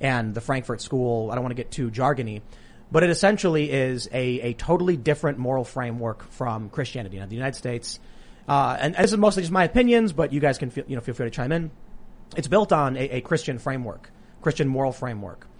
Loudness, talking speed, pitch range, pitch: -24 LUFS, 225 wpm, 120-155 Hz, 130 Hz